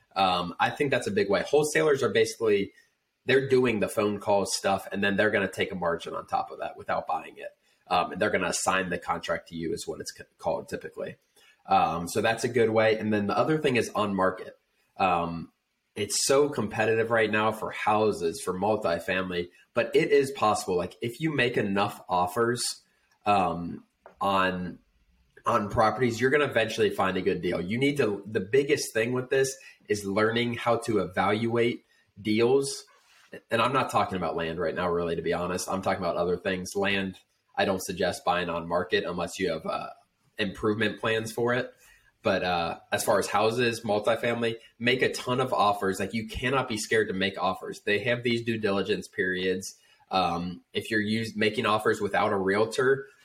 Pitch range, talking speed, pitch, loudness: 100-125 Hz, 195 wpm, 110 Hz, -27 LUFS